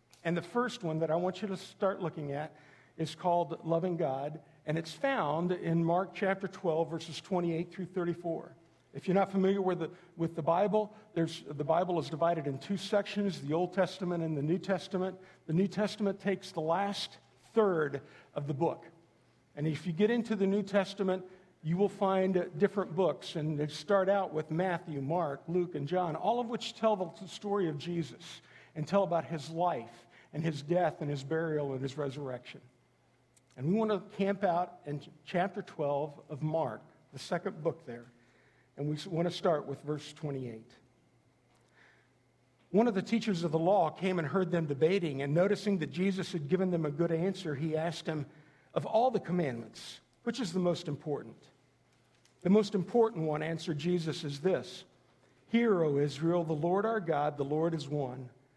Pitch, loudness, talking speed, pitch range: 165 Hz, -33 LUFS, 185 wpm, 150-190 Hz